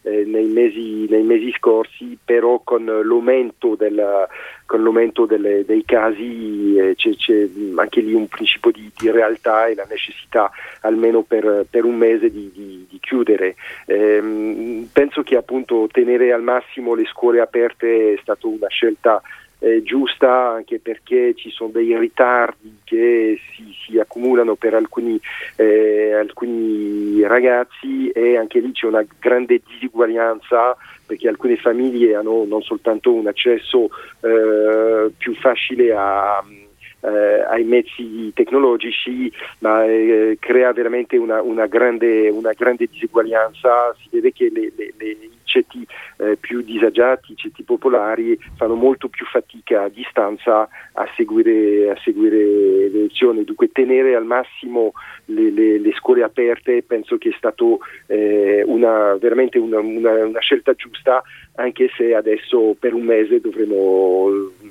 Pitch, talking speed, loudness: 120 Hz, 140 wpm, -17 LUFS